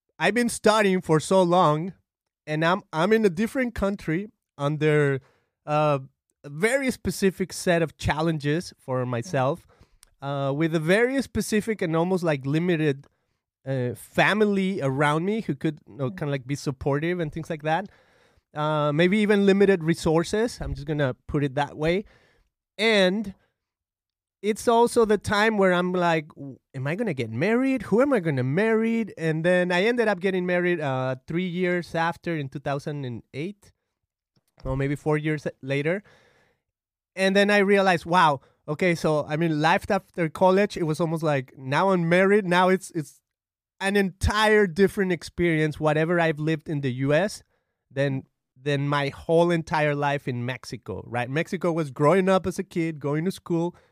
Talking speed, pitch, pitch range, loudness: 165 wpm, 165 Hz, 145-195 Hz, -24 LUFS